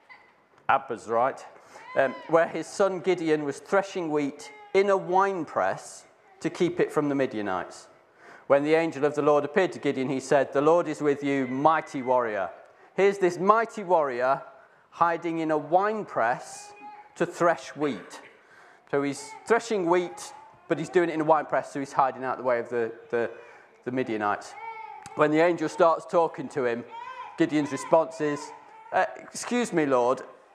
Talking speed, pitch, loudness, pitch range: 165 wpm, 165 Hz, -26 LUFS, 145-210 Hz